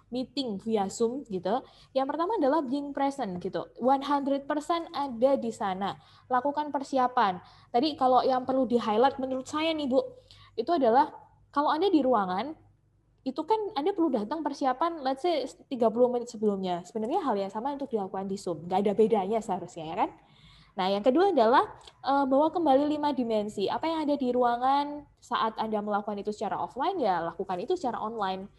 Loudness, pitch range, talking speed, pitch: -28 LUFS, 210-290 Hz, 170 wpm, 260 Hz